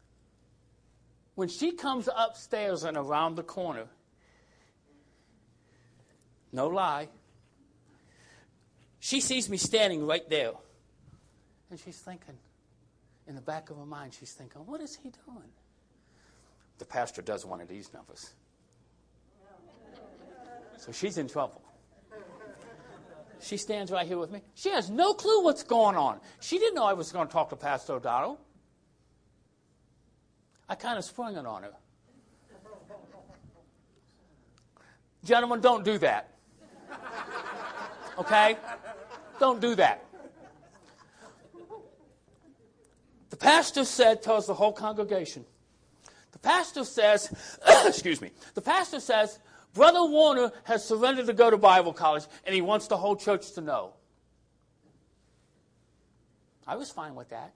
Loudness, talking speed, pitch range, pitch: -27 LUFS, 125 wpm, 170-245 Hz, 210 Hz